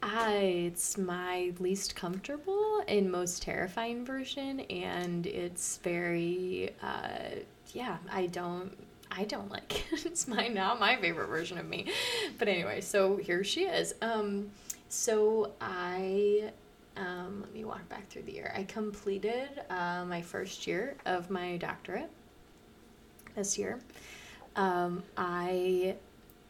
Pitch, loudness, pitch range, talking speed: 195 Hz, -34 LUFS, 180-220 Hz, 130 wpm